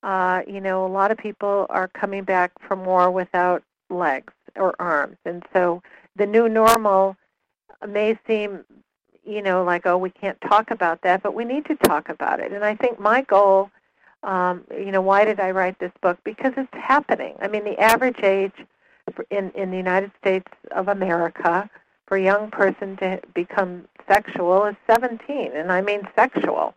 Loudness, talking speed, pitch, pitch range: -21 LUFS, 180 wpm, 195 Hz, 185-210 Hz